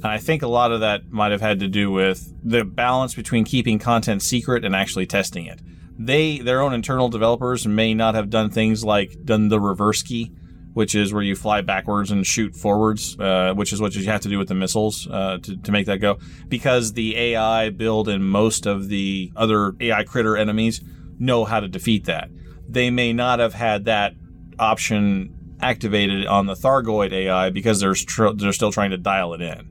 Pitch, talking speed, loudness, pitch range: 105 Hz, 210 wpm, -20 LUFS, 95-115 Hz